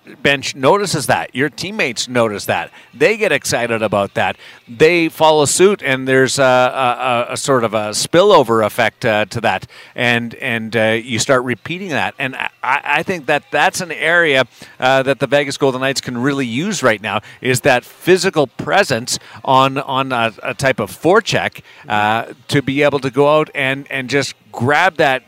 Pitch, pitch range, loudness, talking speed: 130 Hz, 120-145 Hz, -15 LUFS, 185 wpm